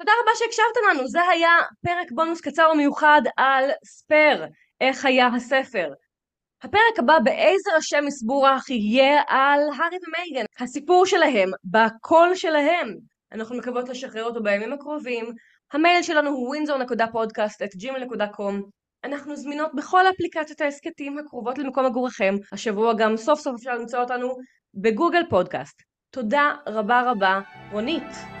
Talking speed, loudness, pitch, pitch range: 130 wpm, -21 LUFS, 275 Hz, 240-315 Hz